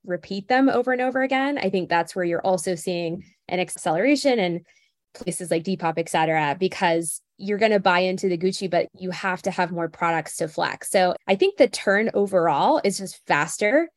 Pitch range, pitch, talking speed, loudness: 175-210 Hz, 185 Hz, 200 wpm, -23 LUFS